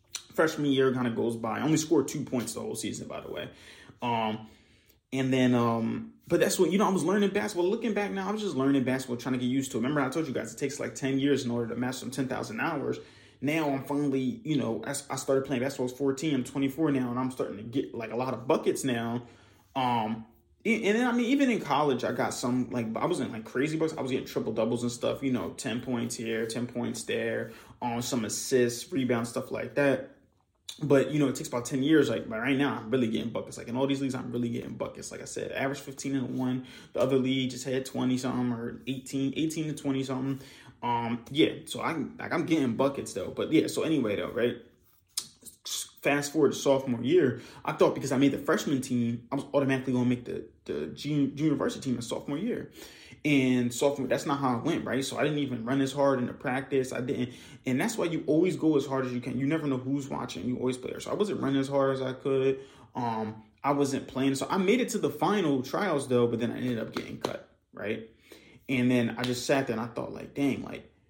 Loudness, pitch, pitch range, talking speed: -29 LUFS, 130 Hz, 120-140 Hz, 250 wpm